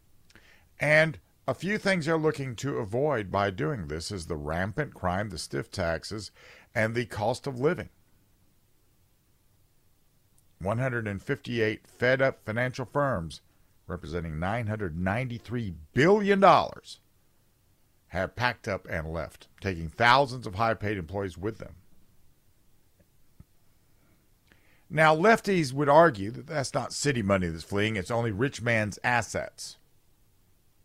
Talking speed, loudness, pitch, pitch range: 115 wpm, -27 LUFS, 105 Hz, 95-125 Hz